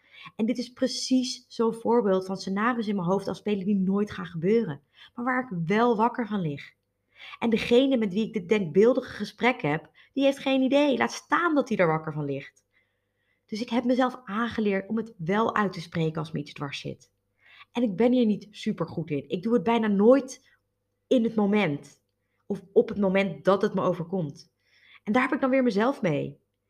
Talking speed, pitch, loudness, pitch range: 210 wpm, 210 Hz, -26 LUFS, 180-240 Hz